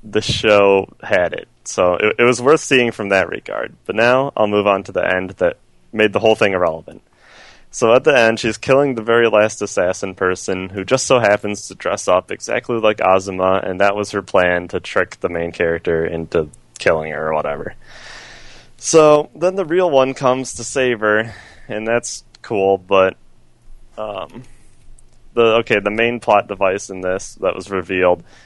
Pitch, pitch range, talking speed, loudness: 105 Hz, 95-115 Hz, 185 wpm, -16 LUFS